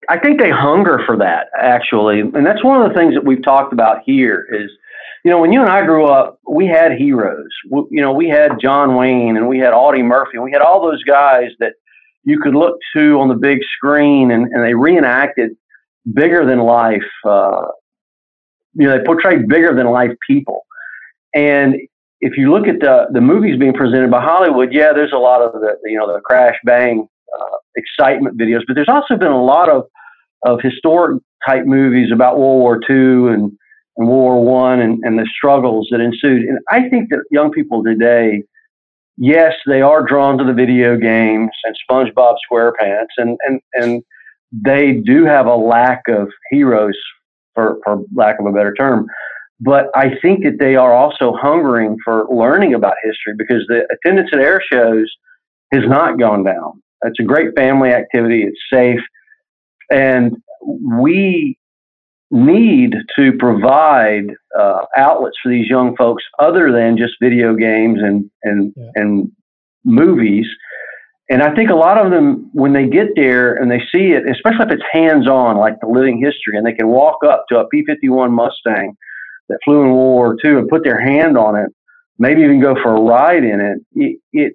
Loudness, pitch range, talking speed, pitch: -12 LUFS, 115-165 Hz, 185 wpm, 130 Hz